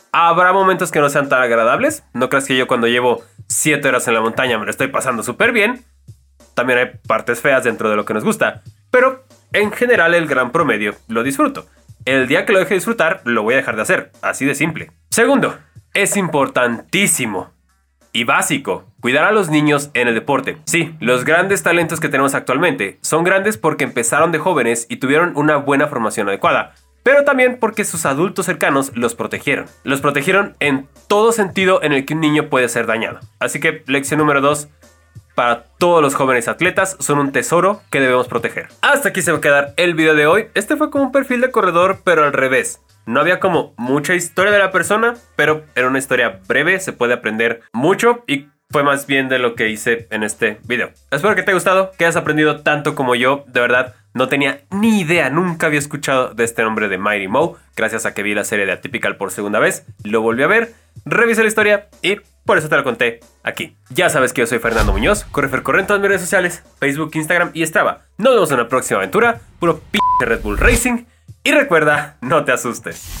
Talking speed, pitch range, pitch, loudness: 215 wpm, 120-185 Hz, 145 Hz, -15 LUFS